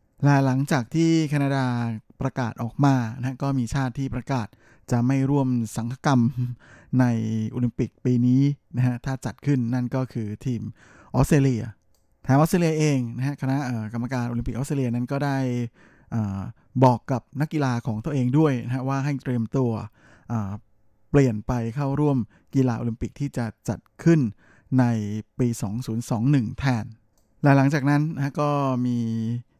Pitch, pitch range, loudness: 125 Hz, 115-135 Hz, -24 LUFS